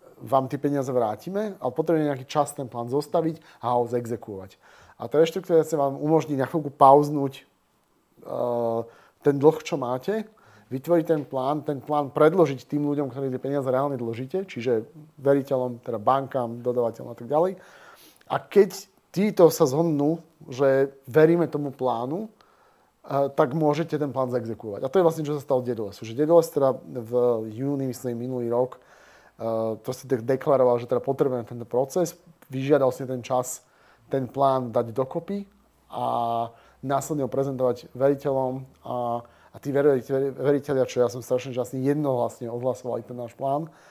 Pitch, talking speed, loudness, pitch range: 135 Hz, 165 wpm, -25 LUFS, 125-150 Hz